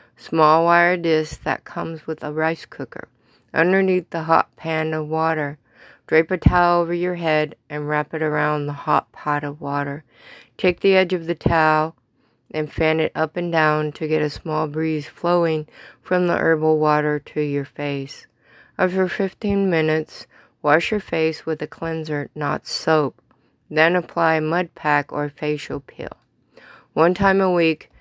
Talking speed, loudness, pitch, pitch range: 165 wpm, -20 LUFS, 160 Hz, 150-170 Hz